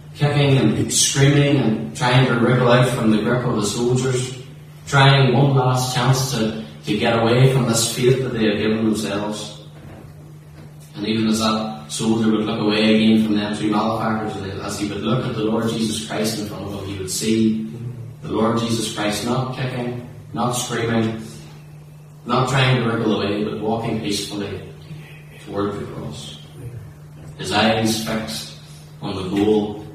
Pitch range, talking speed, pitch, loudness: 105-130 Hz, 170 wpm, 115 Hz, -19 LUFS